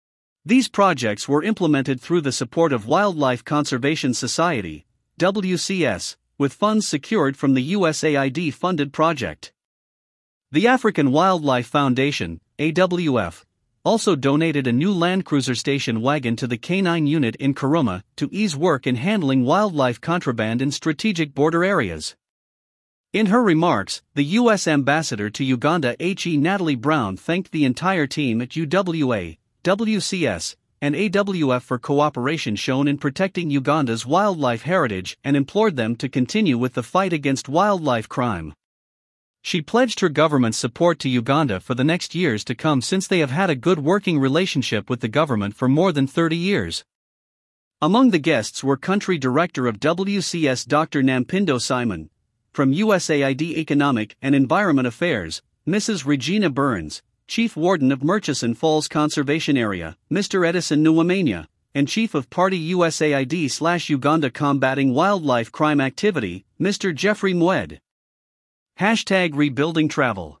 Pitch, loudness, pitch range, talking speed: 150 Hz, -20 LUFS, 130-175 Hz, 140 wpm